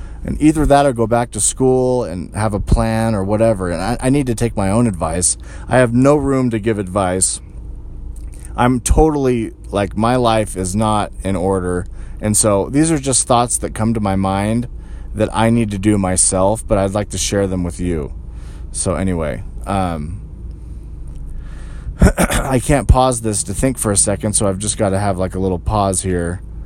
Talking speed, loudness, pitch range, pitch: 195 wpm, -16 LUFS, 90-115 Hz, 100 Hz